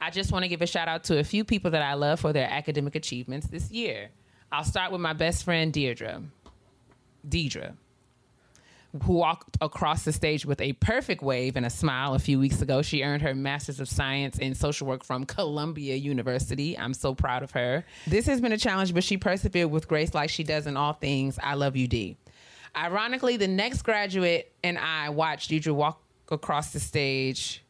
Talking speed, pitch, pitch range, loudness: 205 wpm, 145 Hz, 135-165 Hz, -28 LUFS